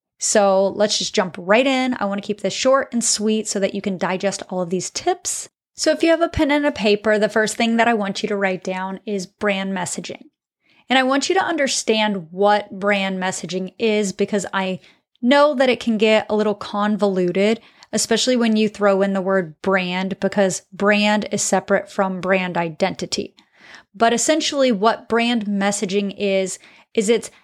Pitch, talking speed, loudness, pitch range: 205 Hz, 190 wpm, -19 LUFS, 195-230 Hz